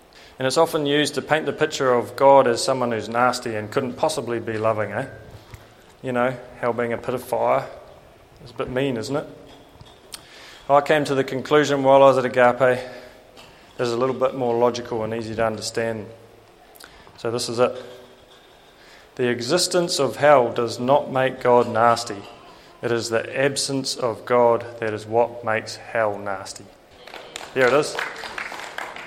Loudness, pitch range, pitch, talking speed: -21 LUFS, 115-135 Hz, 125 Hz, 170 wpm